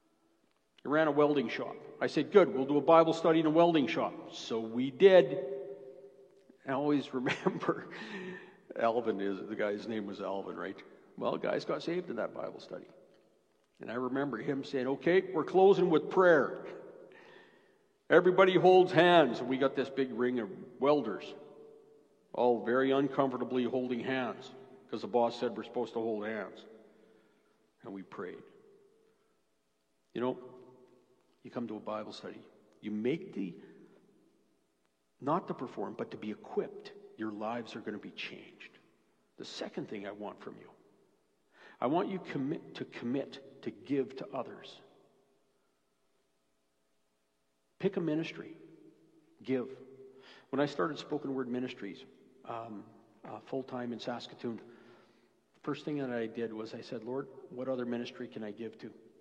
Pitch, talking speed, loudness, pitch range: 130 Hz, 155 wpm, -32 LUFS, 115-160 Hz